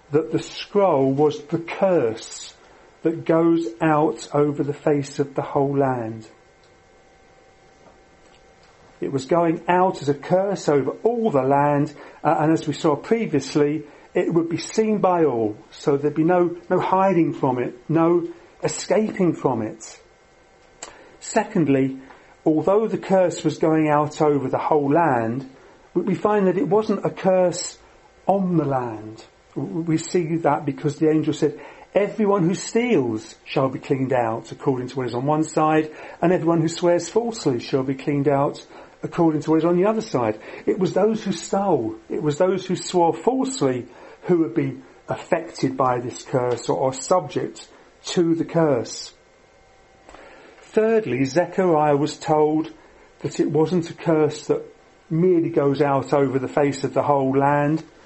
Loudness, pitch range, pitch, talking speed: -21 LUFS, 140-175 Hz, 155 Hz, 160 wpm